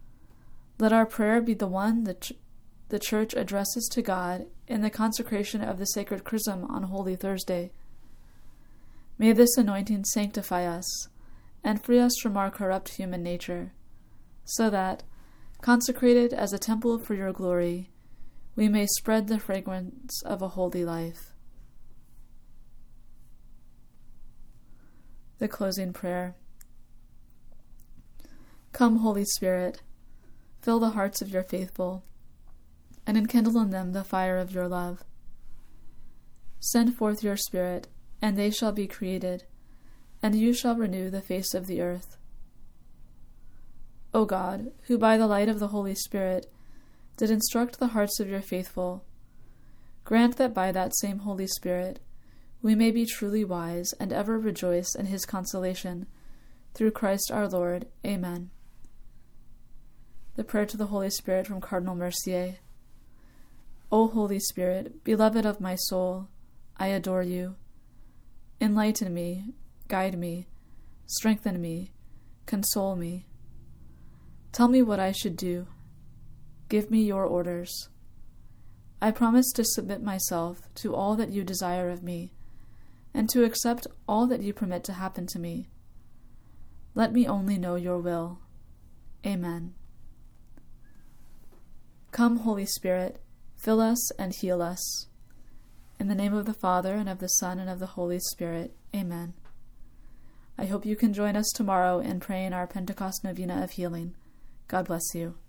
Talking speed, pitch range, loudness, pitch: 135 wpm, 175-215 Hz, -28 LUFS, 190 Hz